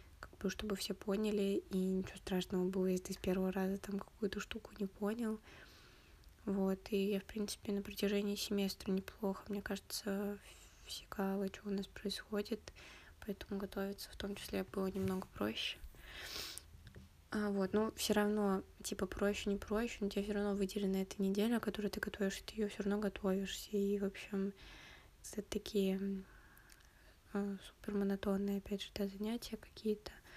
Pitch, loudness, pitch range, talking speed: 200 Hz, -40 LUFS, 195-205 Hz, 155 wpm